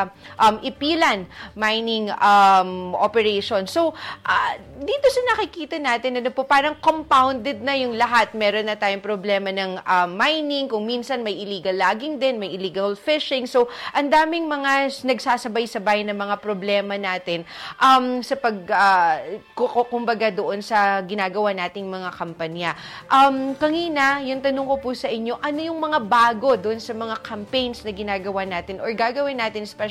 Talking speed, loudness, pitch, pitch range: 155 wpm, -21 LUFS, 235 Hz, 200-275 Hz